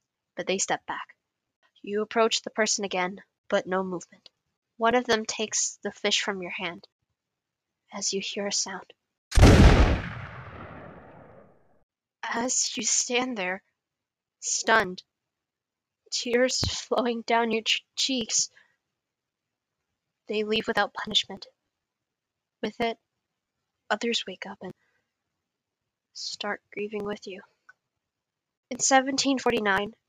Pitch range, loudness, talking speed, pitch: 200-235 Hz, -26 LUFS, 105 wpm, 215 Hz